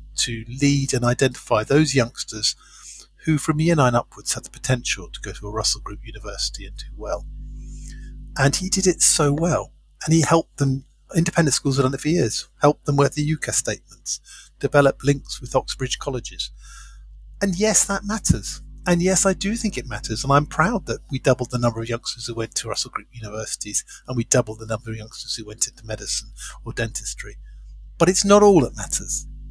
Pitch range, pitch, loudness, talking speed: 110-155 Hz, 130 Hz, -21 LUFS, 195 wpm